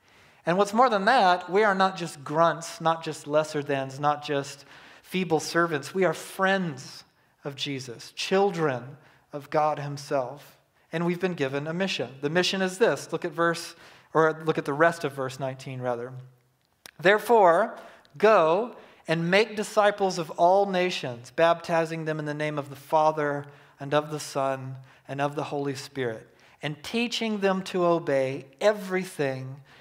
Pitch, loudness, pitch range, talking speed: 155 Hz, -26 LUFS, 140-180 Hz, 160 wpm